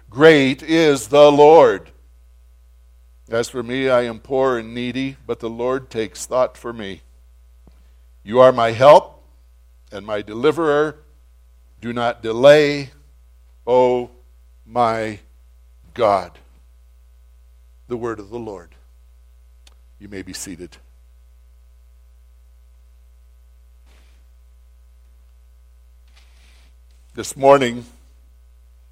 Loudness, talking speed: -16 LUFS, 90 wpm